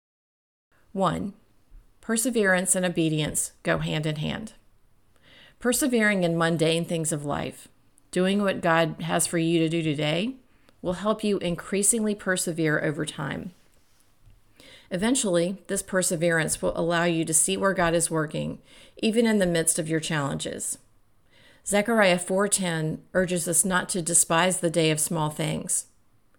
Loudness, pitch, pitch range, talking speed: -24 LUFS, 170 Hz, 155-190 Hz, 140 wpm